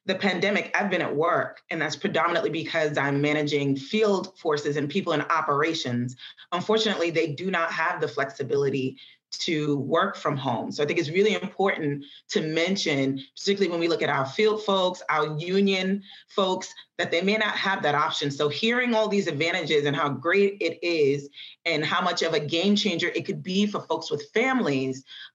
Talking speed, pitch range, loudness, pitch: 185 wpm, 150-195 Hz, -25 LUFS, 170 Hz